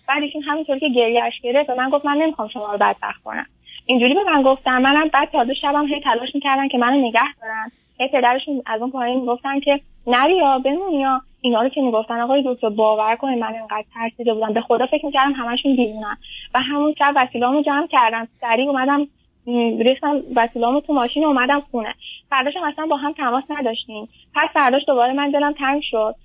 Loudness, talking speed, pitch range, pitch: -19 LUFS, 195 wpm, 235-285 Hz, 260 Hz